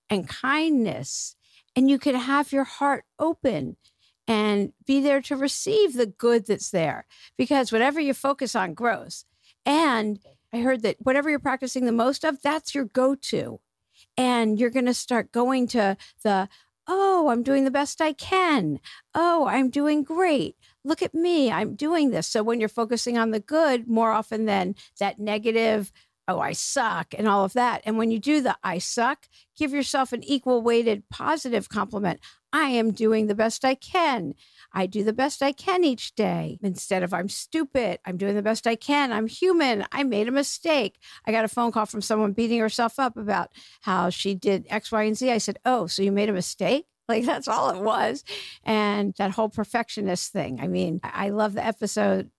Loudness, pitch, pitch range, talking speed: -24 LUFS, 235 Hz, 210-275 Hz, 195 wpm